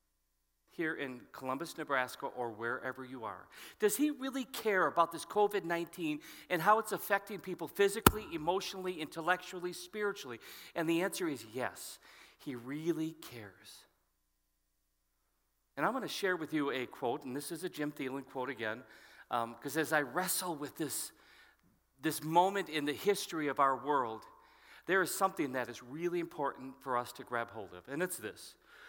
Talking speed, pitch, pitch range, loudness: 165 wpm, 160 Hz, 130-185 Hz, -36 LUFS